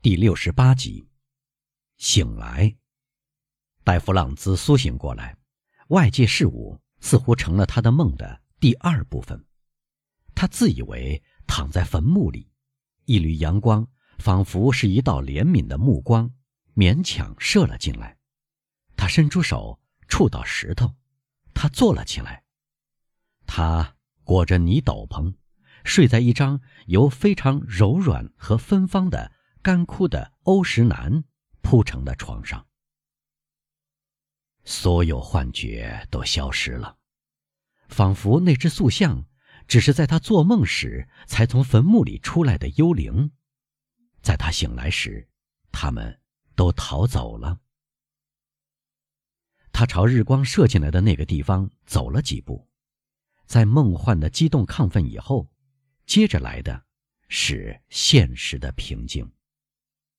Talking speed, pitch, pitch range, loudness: 180 characters per minute, 125 Hz, 95-145 Hz, -21 LUFS